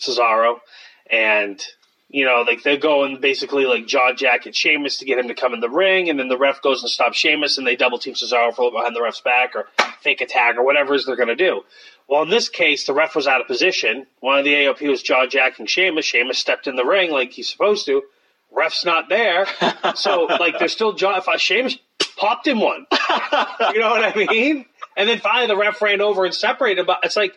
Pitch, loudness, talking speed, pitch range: 145 Hz, -17 LUFS, 235 wpm, 130-215 Hz